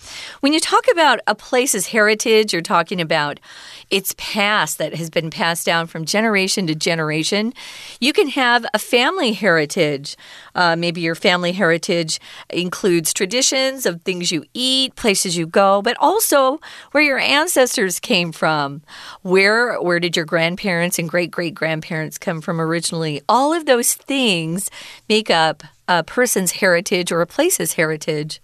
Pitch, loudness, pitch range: 185 Hz, -17 LUFS, 165-230 Hz